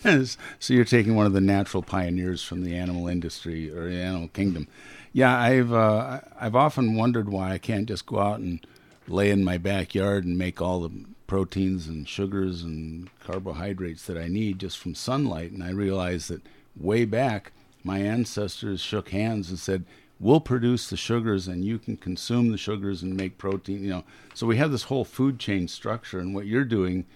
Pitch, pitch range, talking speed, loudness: 95 Hz, 90-115 Hz, 195 wpm, -26 LUFS